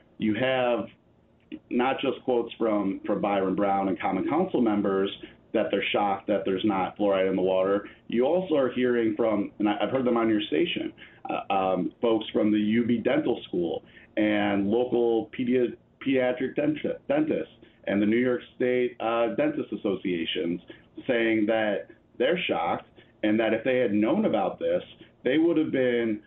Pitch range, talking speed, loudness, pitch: 100-125 Hz, 165 wpm, -26 LUFS, 110 Hz